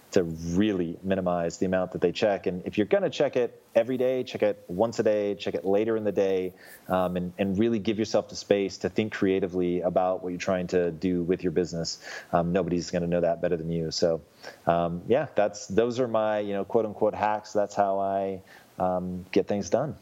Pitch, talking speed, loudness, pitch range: 95 Hz, 220 wpm, -27 LUFS, 90-105 Hz